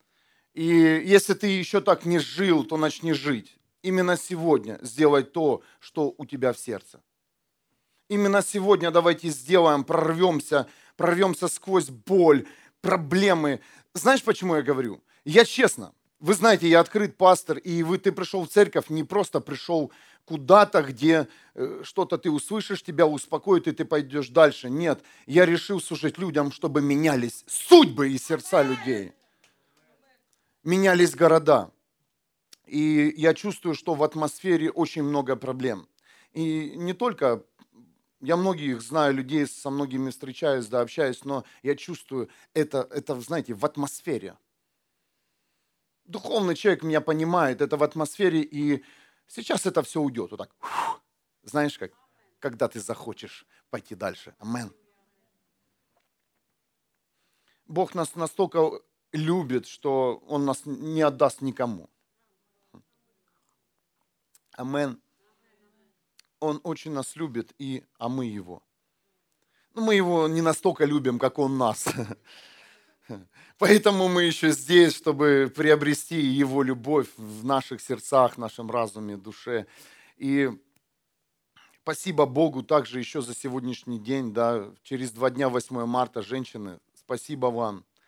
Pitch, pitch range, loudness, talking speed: 155 Hz, 135-175 Hz, -24 LUFS, 125 wpm